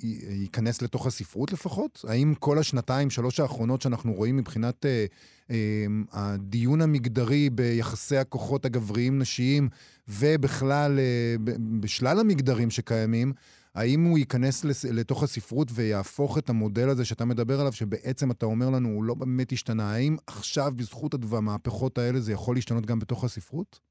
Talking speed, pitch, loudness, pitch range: 140 wpm, 125 Hz, -27 LUFS, 115-135 Hz